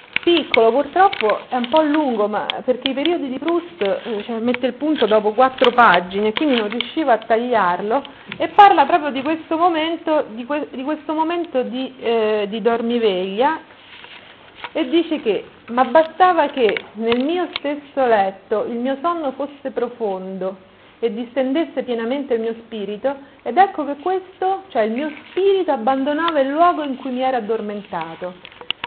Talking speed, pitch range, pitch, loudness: 160 wpm, 230-315 Hz, 270 Hz, -19 LUFS